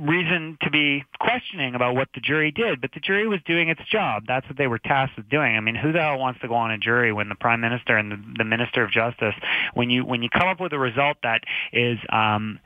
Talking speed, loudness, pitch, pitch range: 265 wpm, -22 LUFS, 130 Hz, 115-155 Hz